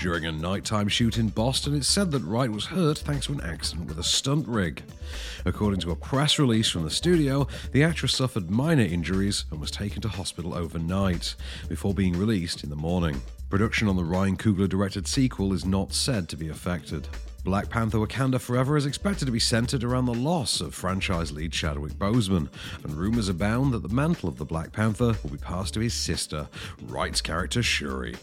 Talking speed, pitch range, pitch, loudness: 200 wpm, 80-120 Hz, 95 Hz, -26 LUFS